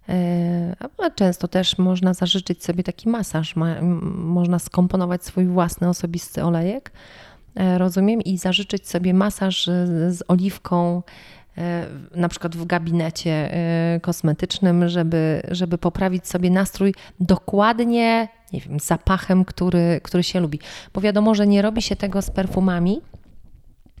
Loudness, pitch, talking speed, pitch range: -21 LUFS, 180 Hz, 120 wpm, 170-190 Hz